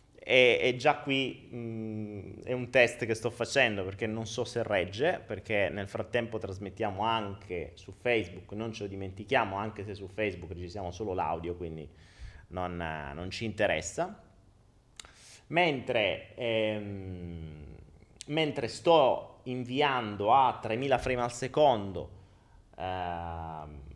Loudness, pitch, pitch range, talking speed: -31 LUFS, 105 Hz, 90-120 Hz, 125 wpm